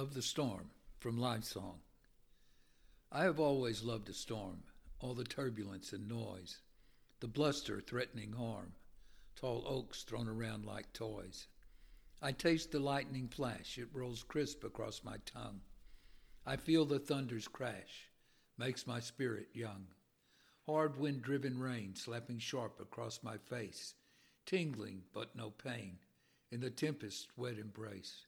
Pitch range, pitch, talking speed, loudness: 105-135 Hz, 120 Hz, 135 wpm, -42 LUFS